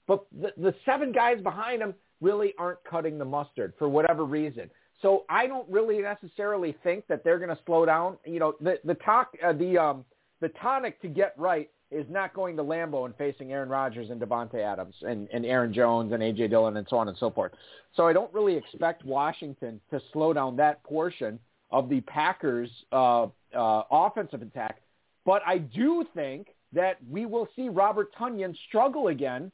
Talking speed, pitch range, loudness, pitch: 195 wpm, 135-195 Hz, -28 LUFS, 165 Hz